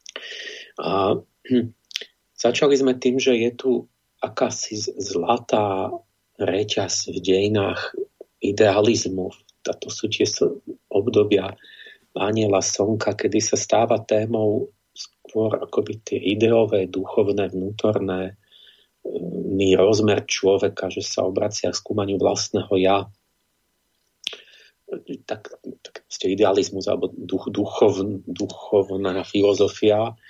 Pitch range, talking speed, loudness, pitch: 100-130 Hz, 95 wpm, -22 LUFS, 110 Hz